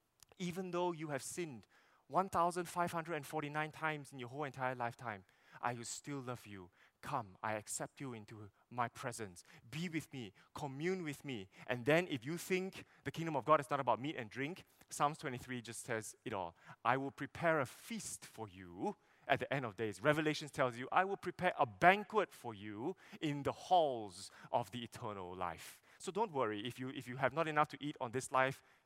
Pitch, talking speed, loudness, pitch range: 135 Hz, 200 wpm, -40 LUFS, 120-155 Hz